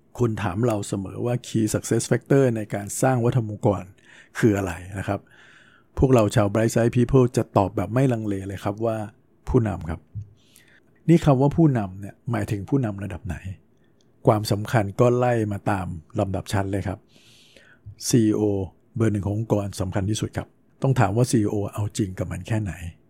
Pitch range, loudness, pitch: 100-120 Hz, -23 LUFS, 110 Hz